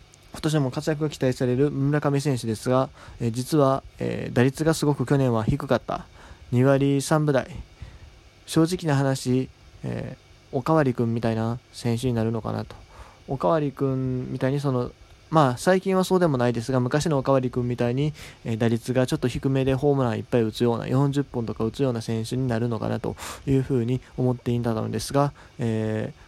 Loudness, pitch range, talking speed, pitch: -24 LUFS, 115-140 Hz, 370 characters per minute, 130 Hz